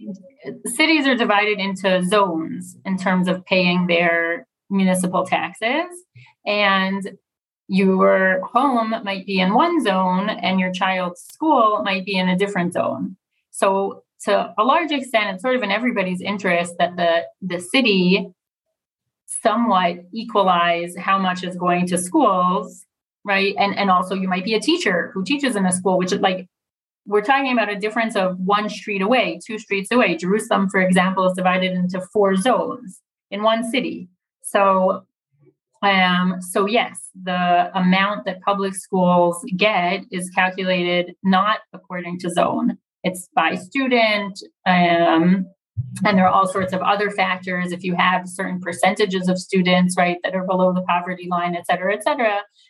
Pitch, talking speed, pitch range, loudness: 190 Hz, 160 wpm, 180-210 Hz, -19 LUFS